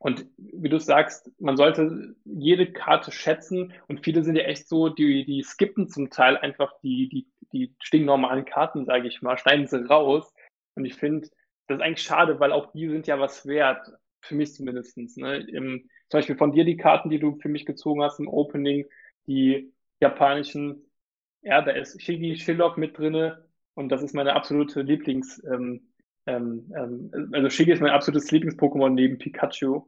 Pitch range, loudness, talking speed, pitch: 140-160 Hz, -24 LUFS, 180 wpm, 145 Hz